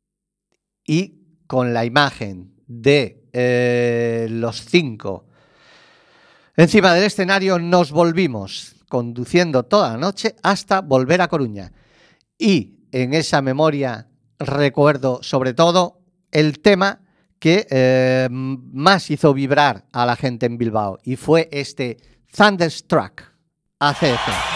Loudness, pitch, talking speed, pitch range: -18 LUFS, 145 Hz, 110 wpm, 125-175 Hz